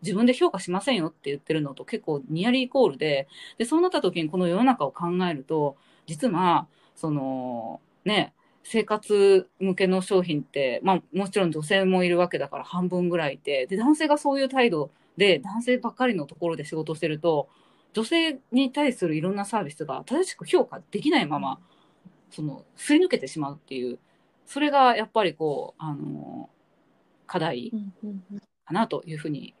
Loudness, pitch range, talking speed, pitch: -25 LUFS, 160-230 Hz, 355 characters per minute, 185 Hz